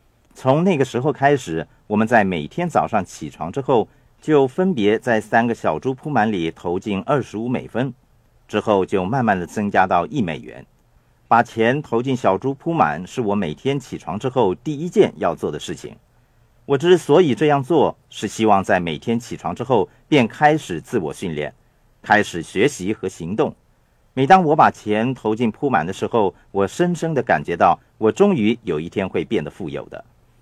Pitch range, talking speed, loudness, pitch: 110-150 Hz, 265 characters per minute, -19 LUFS, 125 Hz